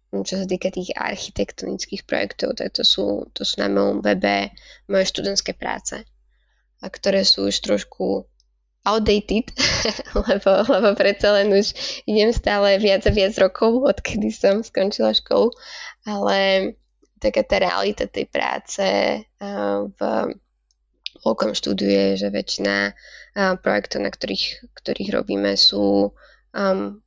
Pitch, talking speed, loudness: 190 Hz, 125 wpm, -20 LUFS